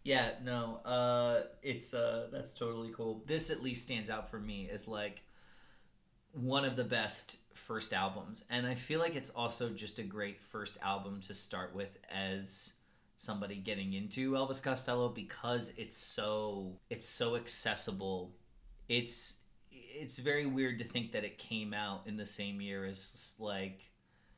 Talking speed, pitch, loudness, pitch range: 160 wpm, 115 Hz, -38 LUFS, 100-125 Hz